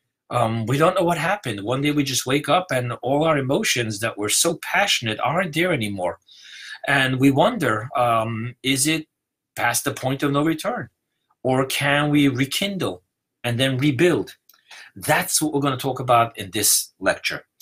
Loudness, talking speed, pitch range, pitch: -21 LUFS, 175 wpm, 120-150 Hz, 135 Hz